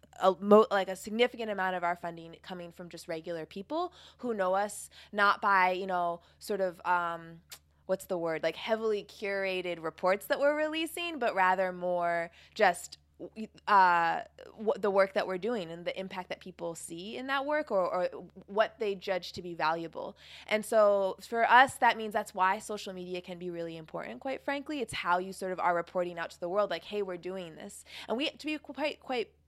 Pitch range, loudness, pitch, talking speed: 175-215 Hz, -31 LUFS, 190 Hz, 205 wpm